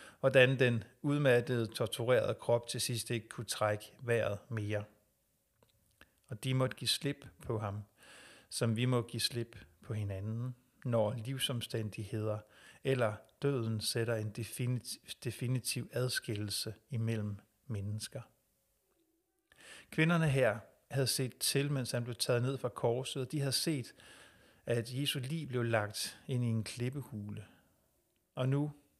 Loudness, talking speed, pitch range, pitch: -35 LUFS, 130 wpm, 110-135 Hz, 120 Hz